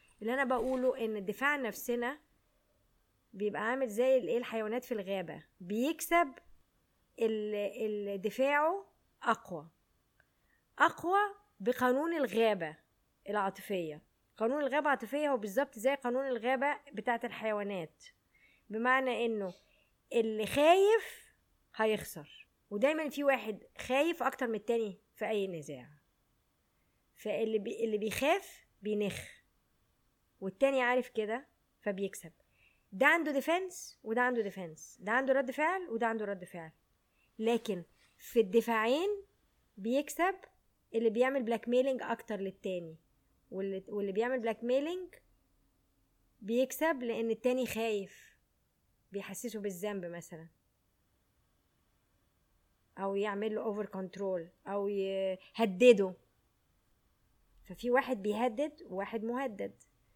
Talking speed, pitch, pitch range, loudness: 100 wpm, 225 Hz, 195-260 Hz, -33 LUFS